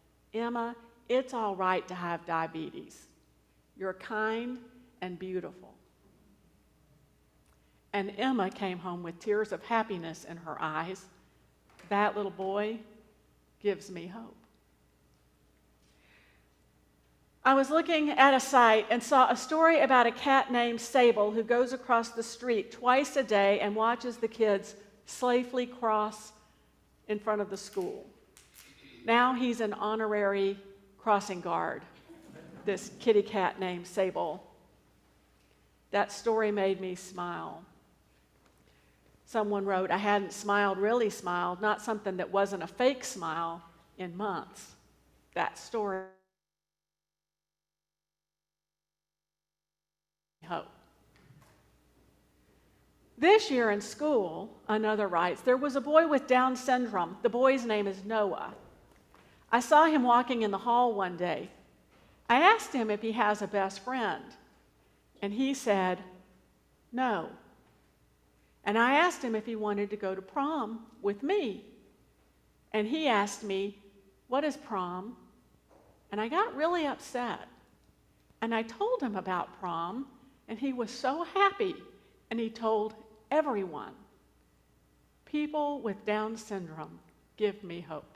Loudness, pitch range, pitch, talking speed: -30 LUFS, 185-245 Hz, 210 Hz, 125 wpm